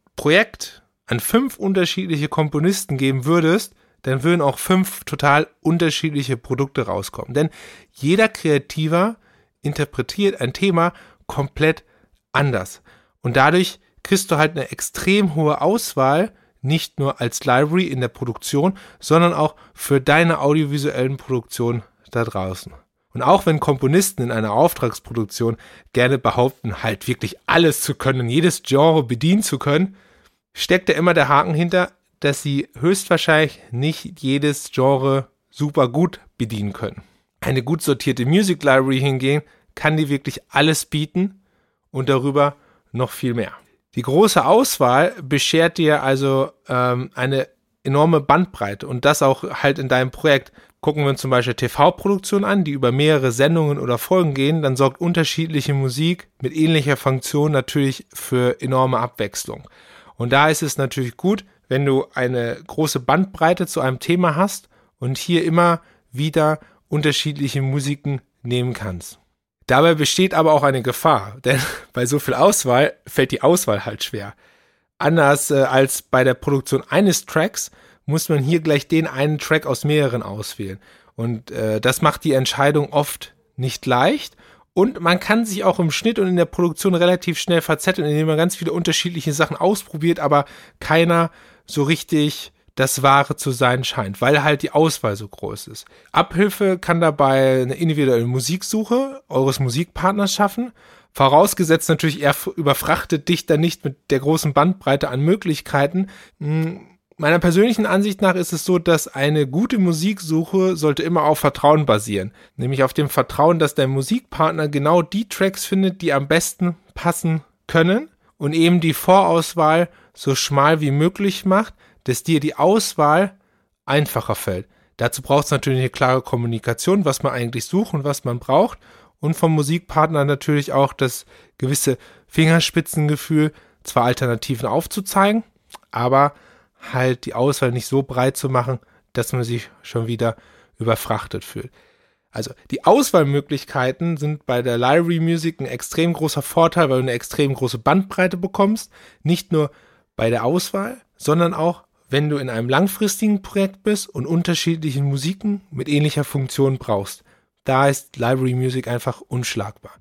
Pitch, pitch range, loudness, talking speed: 150 Hz, 130-170 Hz, -19 LUFS, 150 wpm